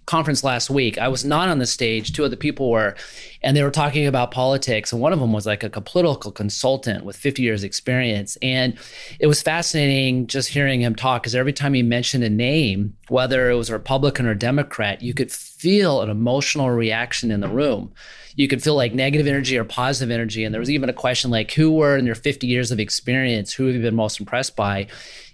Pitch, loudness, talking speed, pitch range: 125 Hz, -20 LUFS, 225 wpm, 115-140 Hz